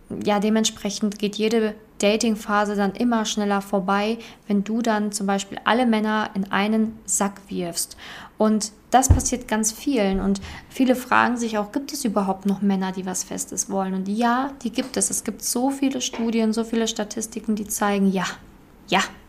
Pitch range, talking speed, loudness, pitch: 200-230 Hz, 175 wpm, -23 LUFS, 215 Hz